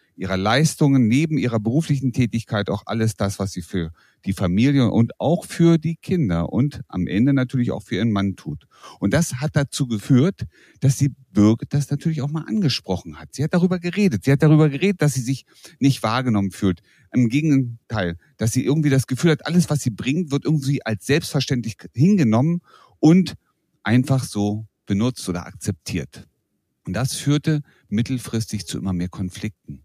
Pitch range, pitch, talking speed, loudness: 105-150 Hz, 130 Hz, 175 wpm, -21 LUFS